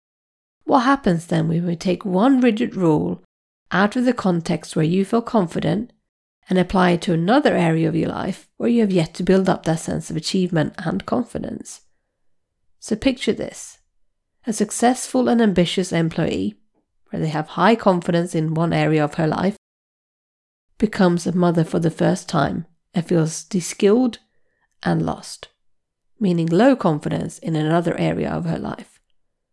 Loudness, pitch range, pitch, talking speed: -20 LUFS, 165-220 Hz, 180 Hz, 160 wpm